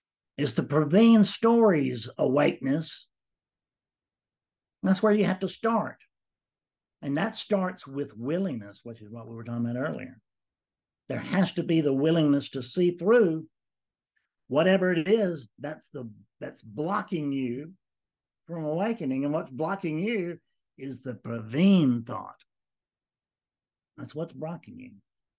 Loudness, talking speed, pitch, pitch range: -26 LUFS, 130 wpm, 155 Hz, 125-185 Hz